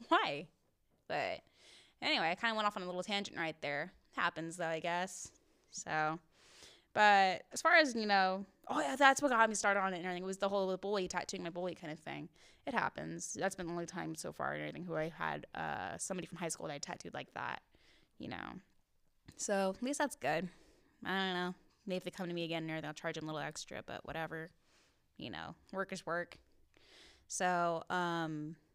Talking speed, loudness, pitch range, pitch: 220 wpm, -37 LUFS, 165-195 Hz, 180 Hz